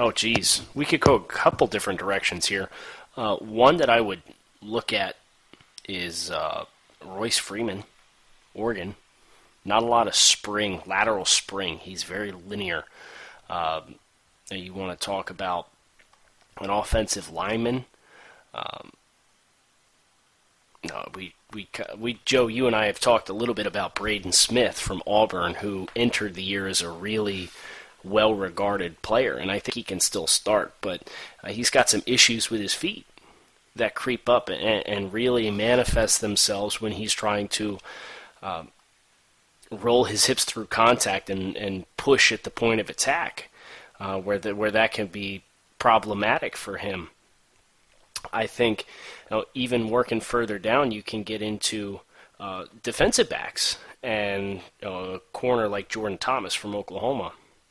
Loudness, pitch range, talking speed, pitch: -24 LUFS, 95-115 Hz, 155 wpm, 105 Hz